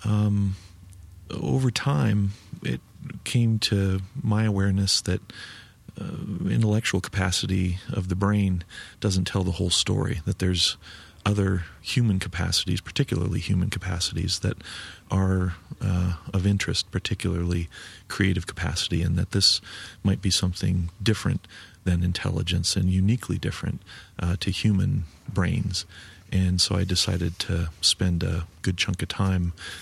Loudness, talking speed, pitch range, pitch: -25 LUFS, 125 wpm, 90-100 Hz, 95 Hz